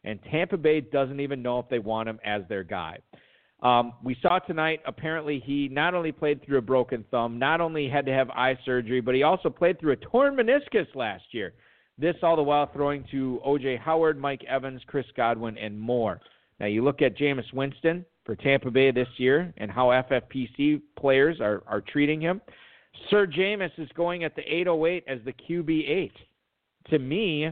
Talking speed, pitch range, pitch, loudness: 190 wpm, 125-160 Hz, 140 Hz, -26 LUFS